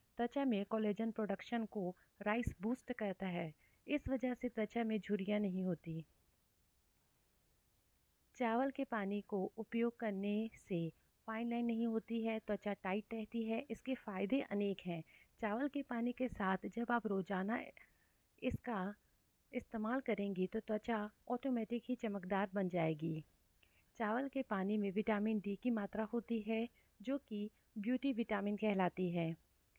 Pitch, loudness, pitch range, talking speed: 215 Hz, -41 LUFS, 195-235 Hz, 145 wpm